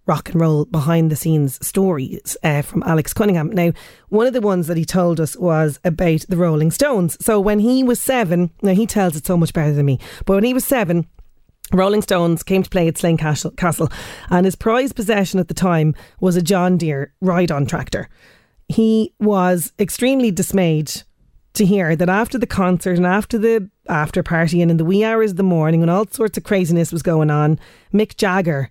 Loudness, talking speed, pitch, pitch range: -17 LUFS, 205 wpm, 180 Hz, 165-205 Hz